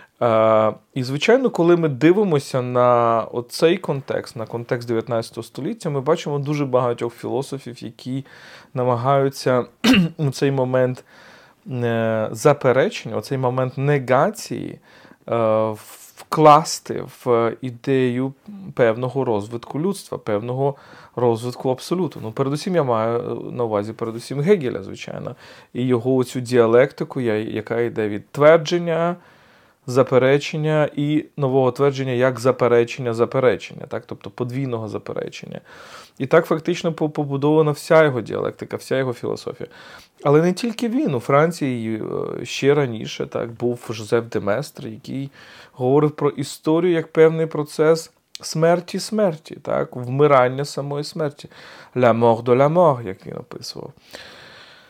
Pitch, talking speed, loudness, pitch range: 135 Hz, 120 wpm, -20 LUFS, 120-155 Hz